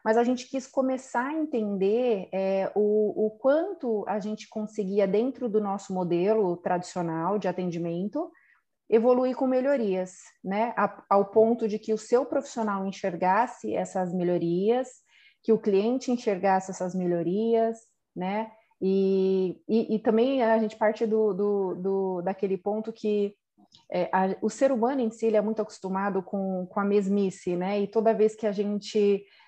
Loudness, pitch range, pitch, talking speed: -27 LUFS, 190-225 Hz, 210 Hz, 160 wpm